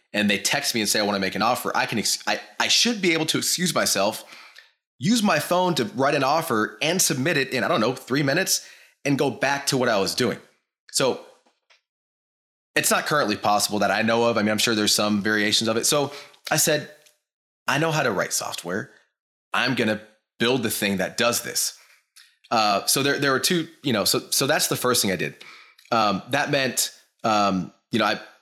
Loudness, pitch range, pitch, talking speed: -22 LUFS, 110-150 Hz, 125 Hz, 225 wpm